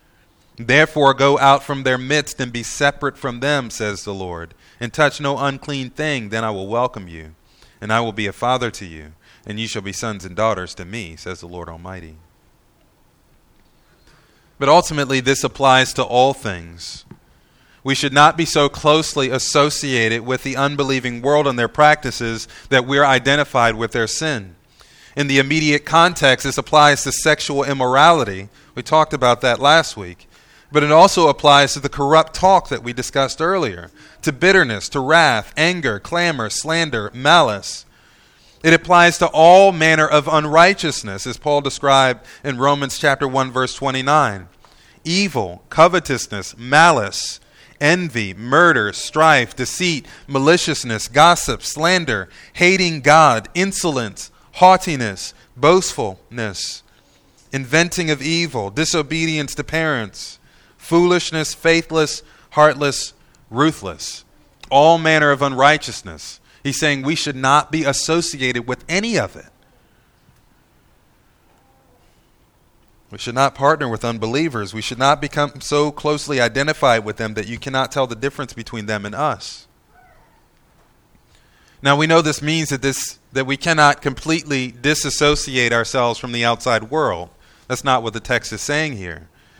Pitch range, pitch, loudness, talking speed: 115-155 Hz, 140 Hz, -16 LUFS, 145 wpm